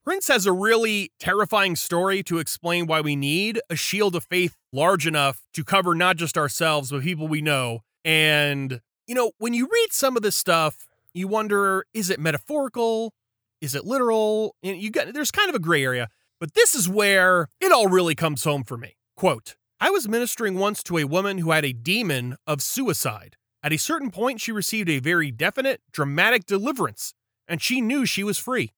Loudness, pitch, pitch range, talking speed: -22 LUFS, 180 Hz, 150-220 Hz, 200 wpm